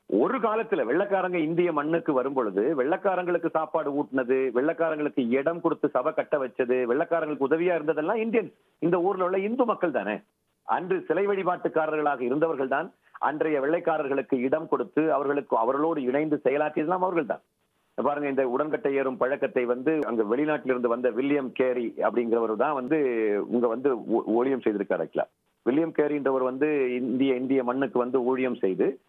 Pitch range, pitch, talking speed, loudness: 130-165 Hz, 150 Hz, 140 wpm, -26 LUFS